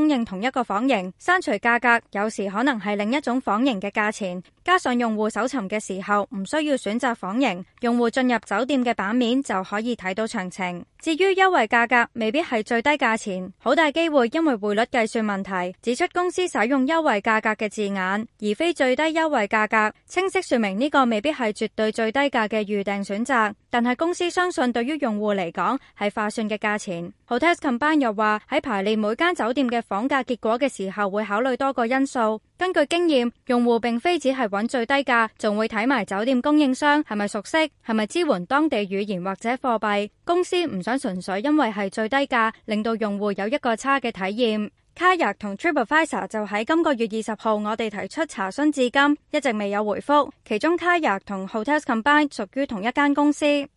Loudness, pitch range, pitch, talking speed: -22 LUFS, 210-280 Hz, 235 Hz, 340 characters per minute